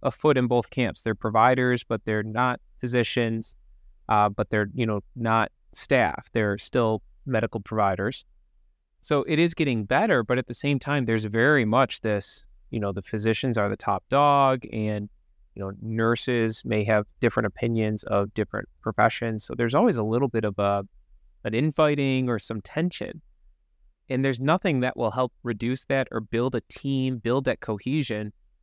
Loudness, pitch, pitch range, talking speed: -25 LUFS, 115 Hz, 105-130 Hz, 175 wpm